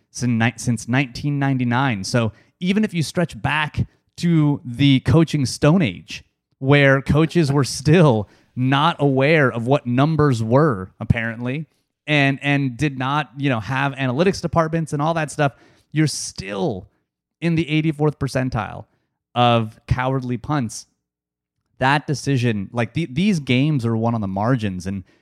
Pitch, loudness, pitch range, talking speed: 135 Hz, -20 LUFS, 115-150 Hz, 140 wpm